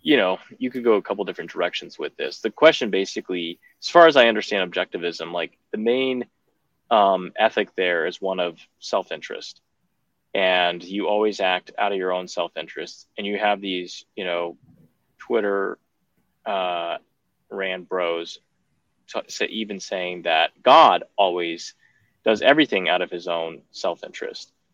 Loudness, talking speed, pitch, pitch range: -22 LUFS, 160 wpm, 90 Hz, 85-100 Hz